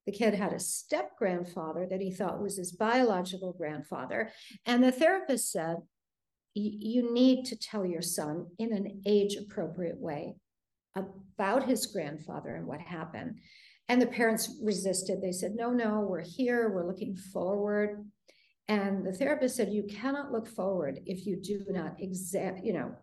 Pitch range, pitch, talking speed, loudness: 185-230 Hz, 205 Hz, 160 wpm, -32 LUFS